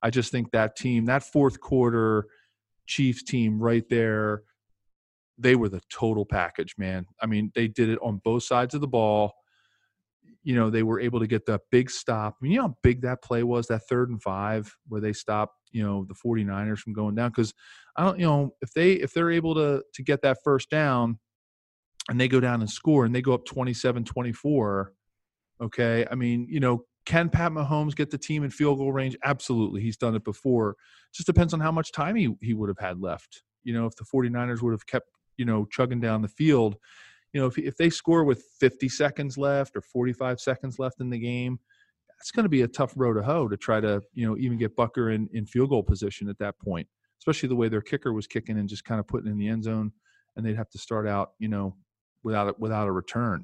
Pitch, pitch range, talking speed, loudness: 120 Hz, 110-135 Hz, 230 wpm, -26 LUFS